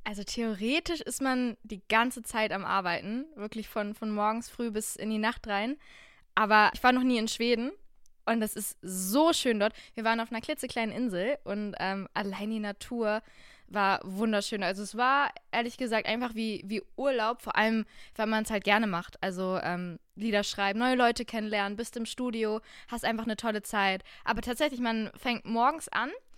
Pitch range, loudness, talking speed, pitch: 205-240 Hz, -30 LUFS, 190 wpm, 220 Hz